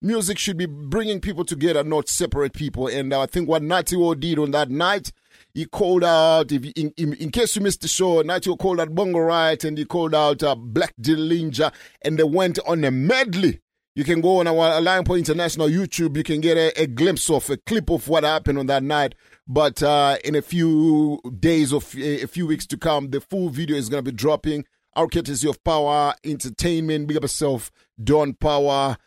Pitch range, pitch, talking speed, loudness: 145-170 Hz, 155 Hz, 215 wpm, -21 LUFS